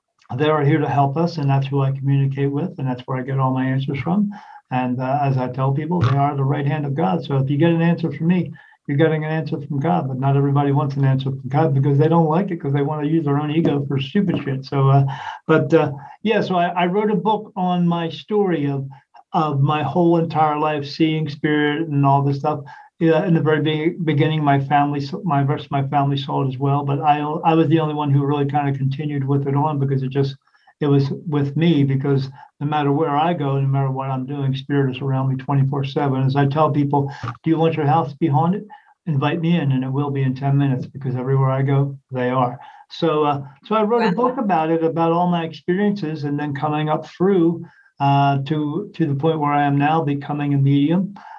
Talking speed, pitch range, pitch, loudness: 245 wpm, 140-160 Hz, 145 Hz, -19 LUFS